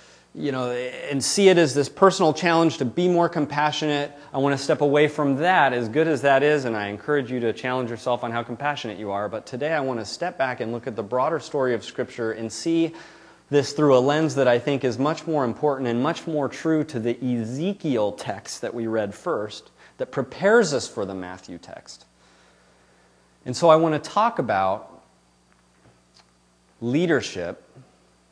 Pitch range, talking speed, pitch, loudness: 110-150 Hz, 195 wpm, 130 Hz, -23 LUFS